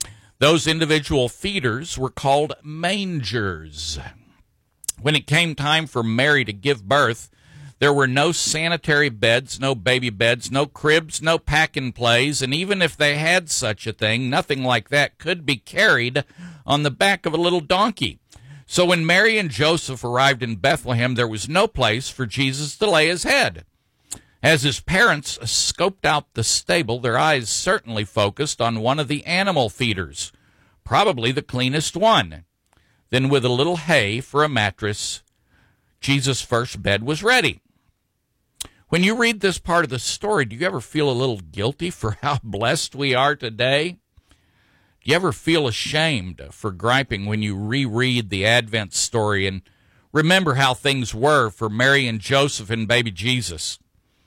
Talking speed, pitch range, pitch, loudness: 165 wpm, 115-155 Hz, 135 Hz, -20 LUFS